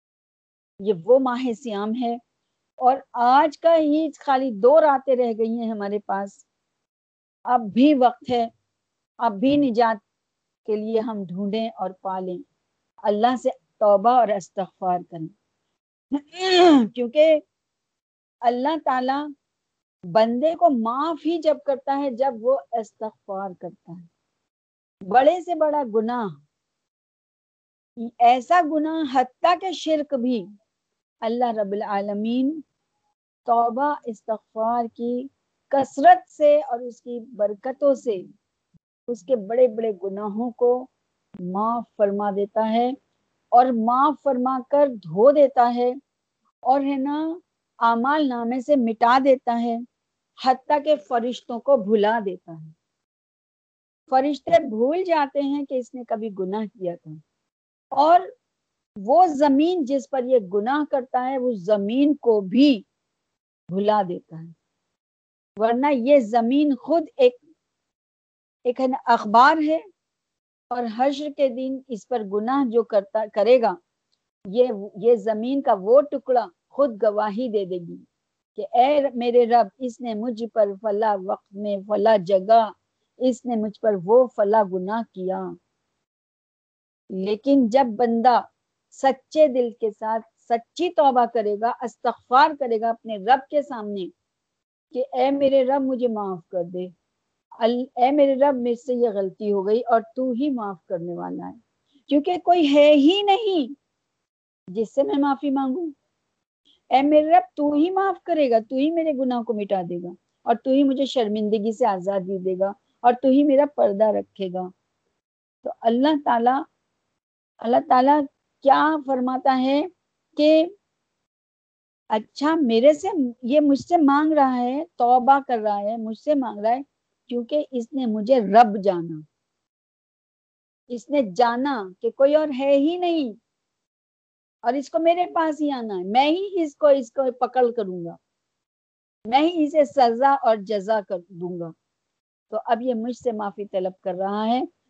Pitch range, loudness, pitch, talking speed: 220-280 Hz, -21 LUFS, 245 Hz, 145 wpm